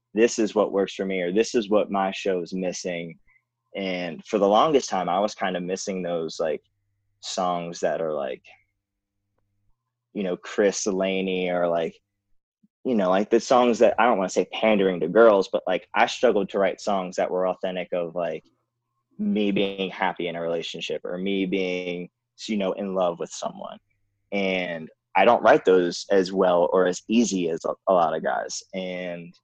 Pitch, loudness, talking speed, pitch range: 95 Hz, -24 LUFS, 190 wpm, 90-100 Hz